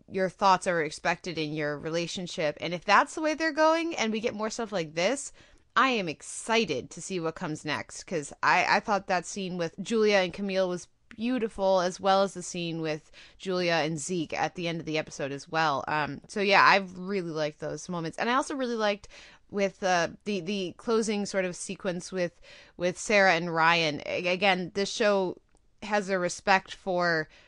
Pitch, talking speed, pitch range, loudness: 185 Hz, 200 wpm, 165-205 Hz, -28 LUFS